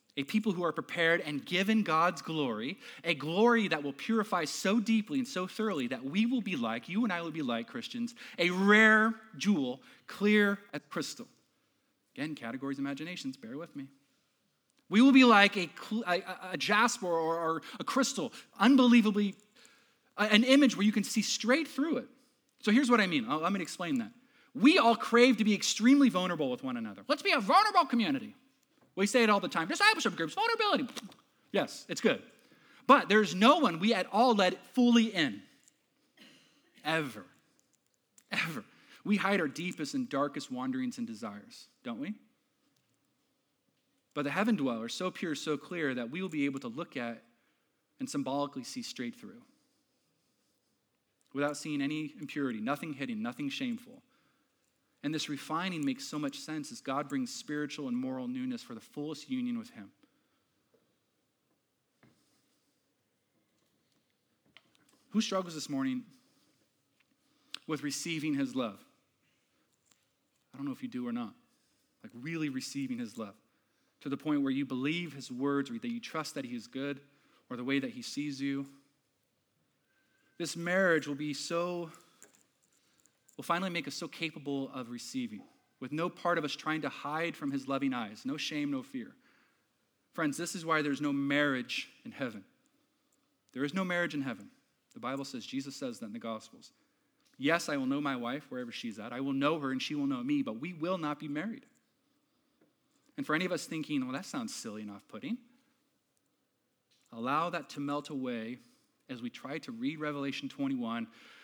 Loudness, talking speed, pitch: -31 LUFS, 170 wpm, 215 Hz